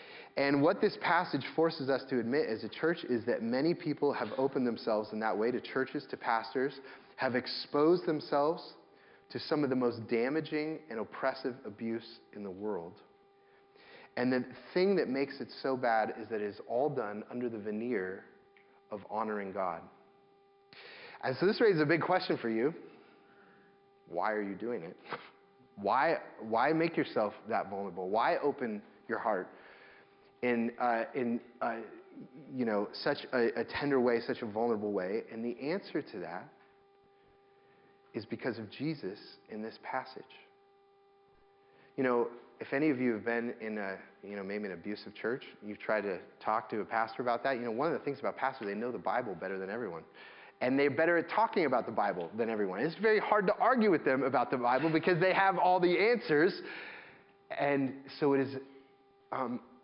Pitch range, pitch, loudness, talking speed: 115-170 Hz, 130 Hz, -33 LUFS, 185 wpm